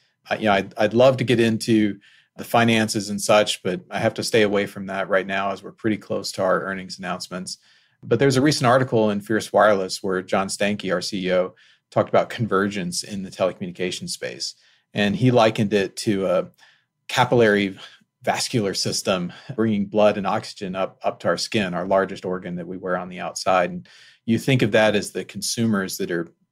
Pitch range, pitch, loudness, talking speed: 95-120 Hz, 105 Hz, -22 LUFS, 200 wpm